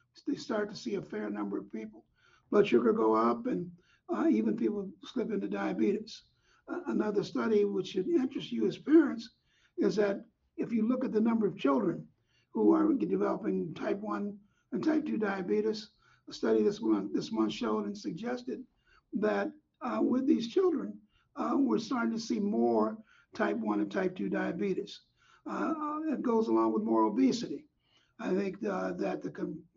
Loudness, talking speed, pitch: -31 LUFS, 175 wpm, 210 Hz